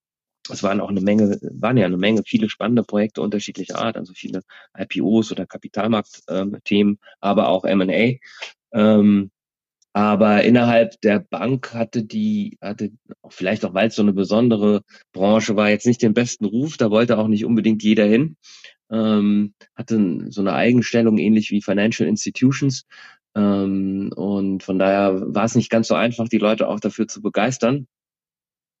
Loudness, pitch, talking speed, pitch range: -19 LUFS, 110 Hz, 160 wpm, 100-115 Hz